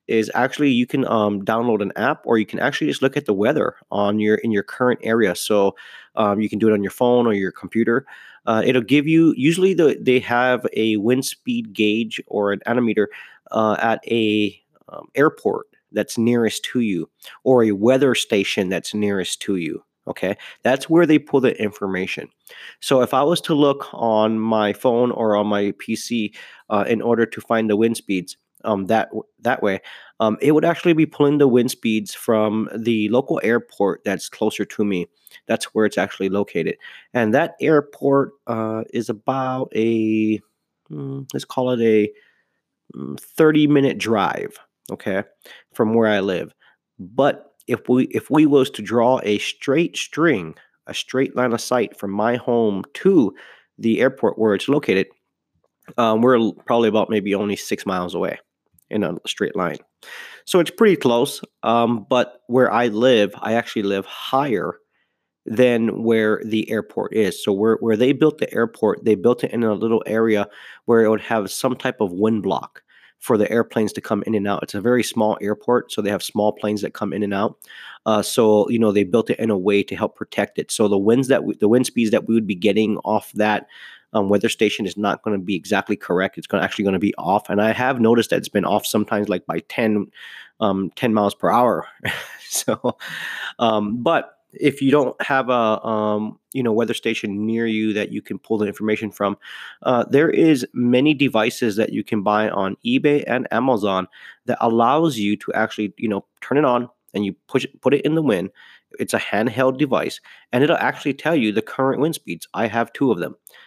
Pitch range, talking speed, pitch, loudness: 105-125 Hz, 200 wpm, 110 Hz, -20 LUFS